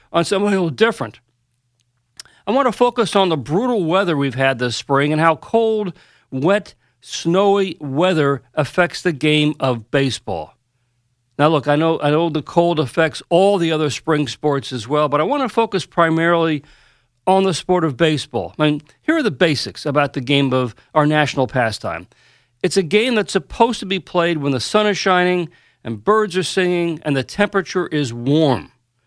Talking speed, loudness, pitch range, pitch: 185 wpm, -18 LUFS, 135-190 Hz, 155 Hz